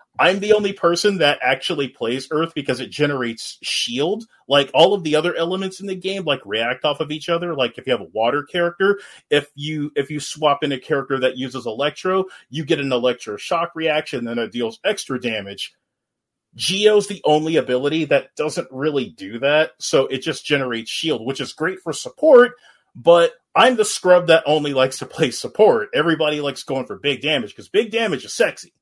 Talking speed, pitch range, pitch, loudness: 200 wpm, 135-180 Hz, 150 Hz, -19 LUFS